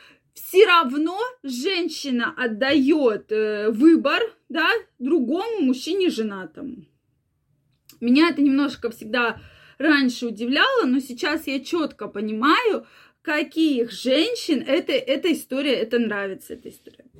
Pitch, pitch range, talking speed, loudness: 275 Hz, 235-320 Hz, 100 wpm, -21 LUFS